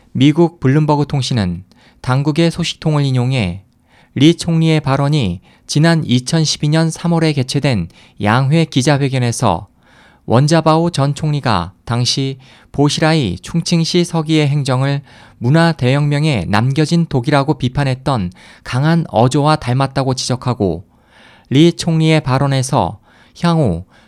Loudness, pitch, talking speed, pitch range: -15 LUFS, 140 Hz, 260 characters per minute, 125-155 Hz